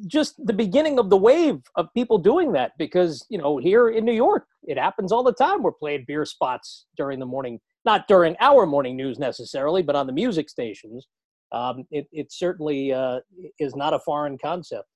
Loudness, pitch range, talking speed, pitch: -22 LUFS, 140-235 Hz, 200 wpm, 165 Hz